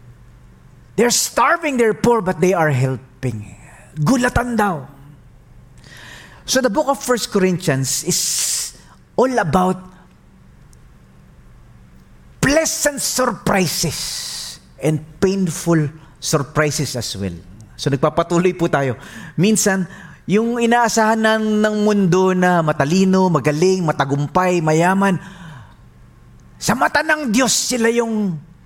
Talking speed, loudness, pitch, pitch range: 95 wpm, -17 LUFS, 175 Hz, 140-210 Hz